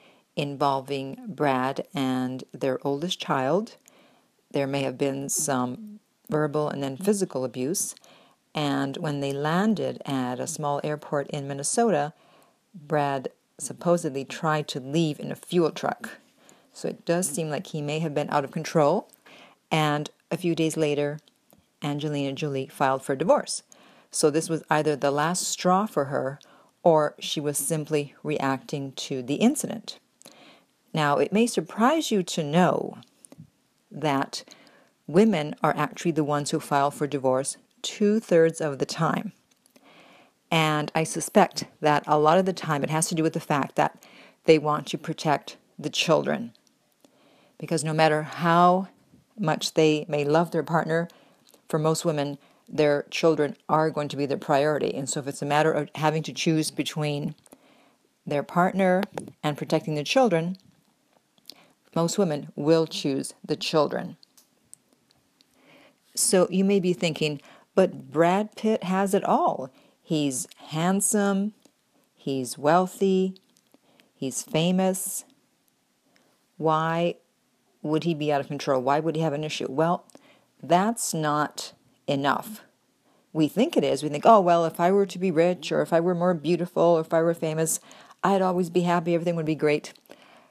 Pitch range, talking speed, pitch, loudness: 145-180 Hz, 150 wpm, 160 Hz, -25 LUFS